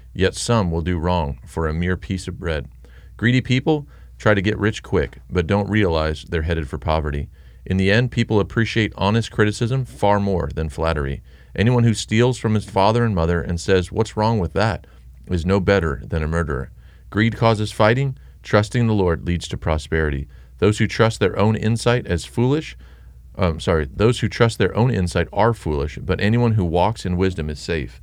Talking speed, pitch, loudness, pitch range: 190 wpm, 95 Hz, -20 LUFS, 80-110 Hz